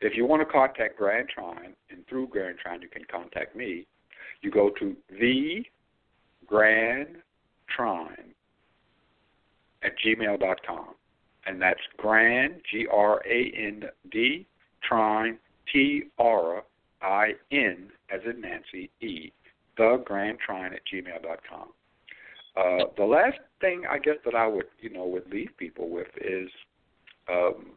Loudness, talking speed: -26 LUFS, 135 wpm